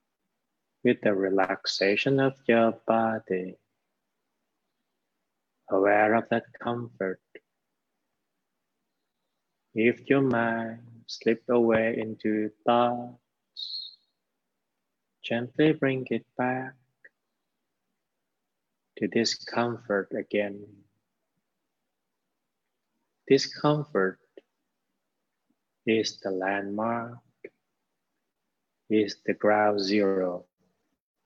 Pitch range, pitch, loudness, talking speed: 100-120 Hz, 115 Hz, -27 LUFS, 65 wpm